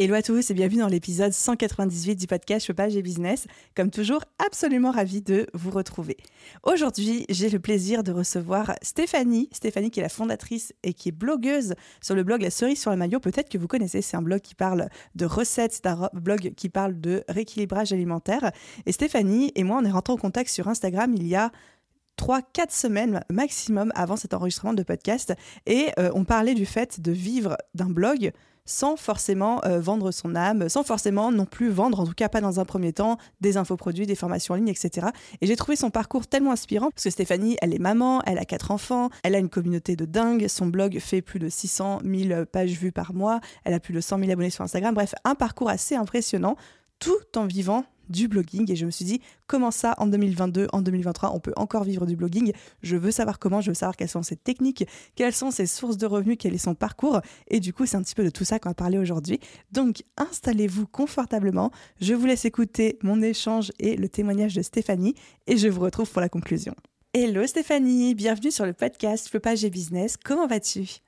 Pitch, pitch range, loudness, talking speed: 205 Hz, 185-230 Hz, -25 LUFS, 220 wpm